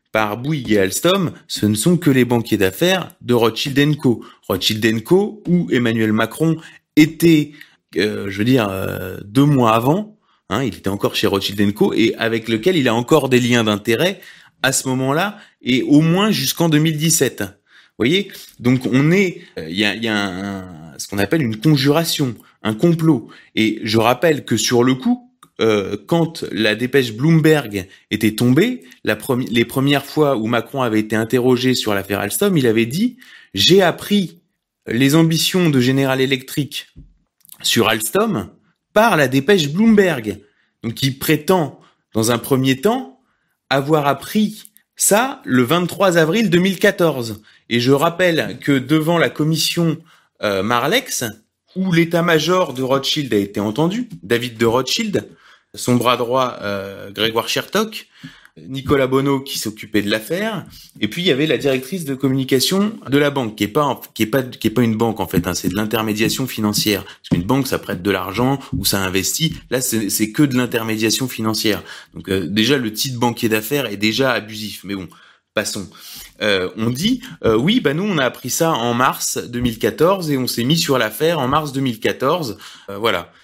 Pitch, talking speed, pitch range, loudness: 130 Hz, 175 wpm, 110-160 Hz, -17 LUFS